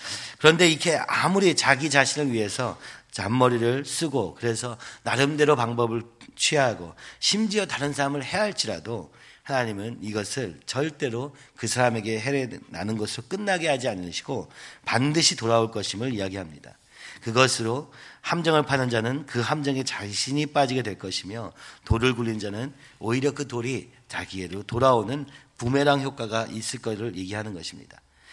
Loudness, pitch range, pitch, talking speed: -25 LUFS, 110-140 Hz, 125 Hz, 335 characters per minute